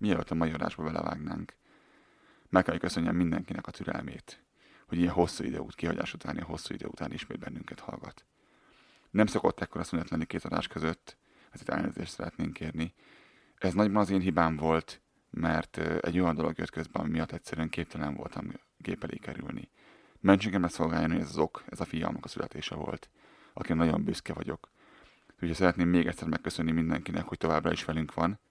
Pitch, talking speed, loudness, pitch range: 85 Hz, 180 wpm, -32 LUFS, 80-90 Hz